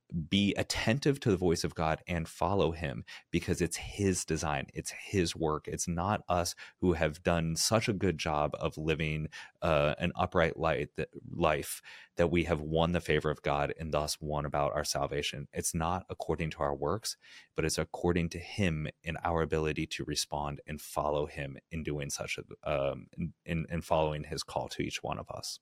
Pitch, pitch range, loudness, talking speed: 80 Hz, 75-85 Hz, -33 LUFS, 195 wpm